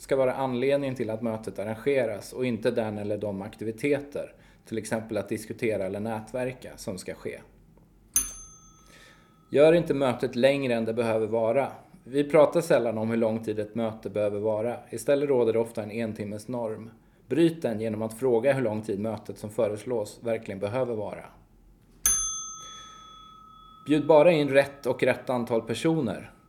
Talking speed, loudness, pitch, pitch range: 160 wpm, -27 LUFS, 115 Hz, 110-140 Hz